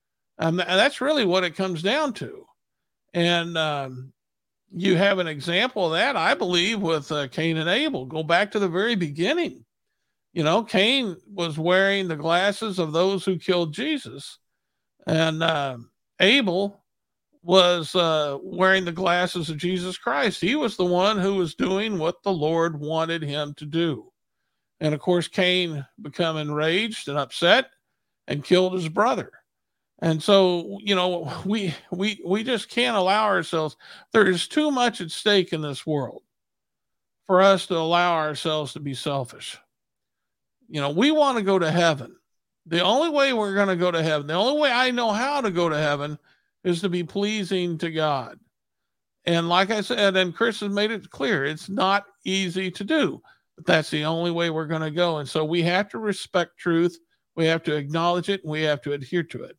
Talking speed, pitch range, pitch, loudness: 185 wpm, 160-200 Hz, 180 Hz, -23 LUFS